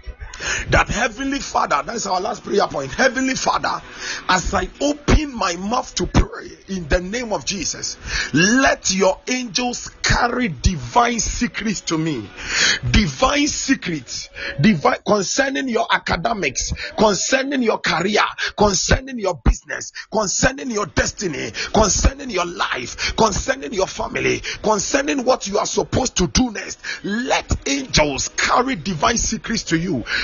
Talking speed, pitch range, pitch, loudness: 130 wpm, 180-260 Hz, 220 Hz, -19 LUFS